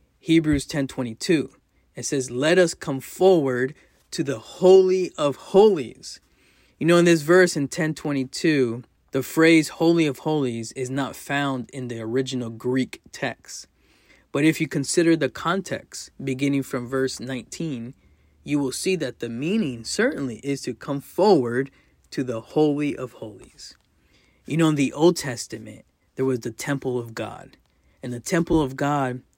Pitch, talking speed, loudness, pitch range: 140 Hz, 155 wpm, -23 LUFS, 125-160 Hz